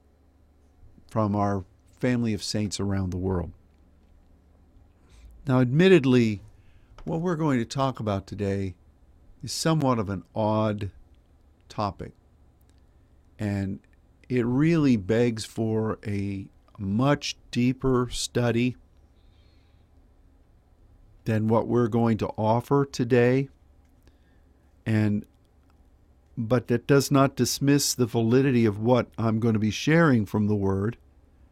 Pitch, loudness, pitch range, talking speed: 100 Hz, -25 LUFS, 85-120 Hz, 110 wpm